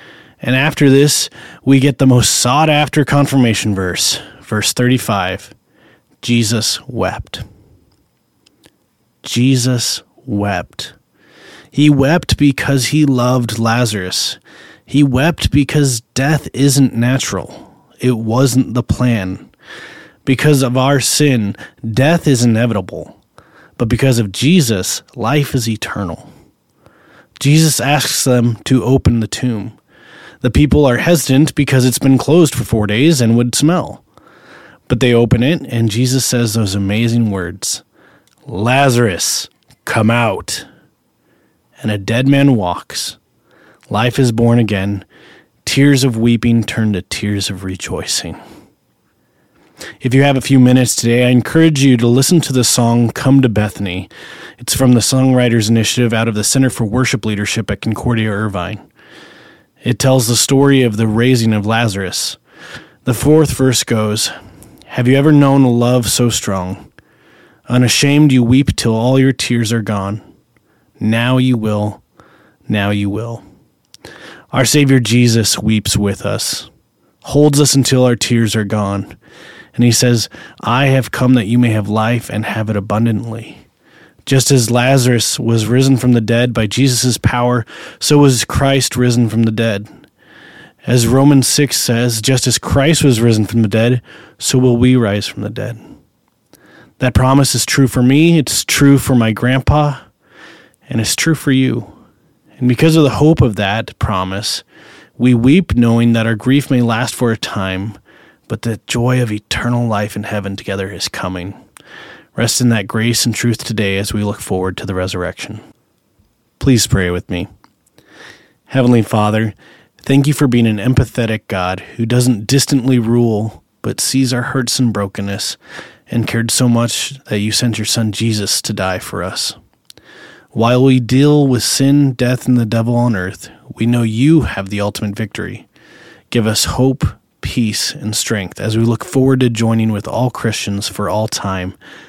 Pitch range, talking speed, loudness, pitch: 110-130 Hz, 155 wpm, -13 LUFS, 120 Hz